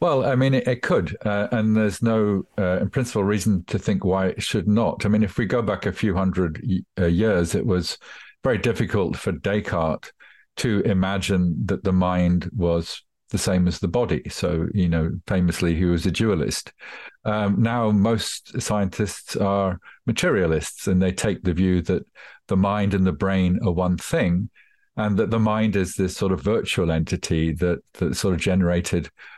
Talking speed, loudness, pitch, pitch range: 190 wpm, -22 LUFS, 95 Hz, 90-105 Hz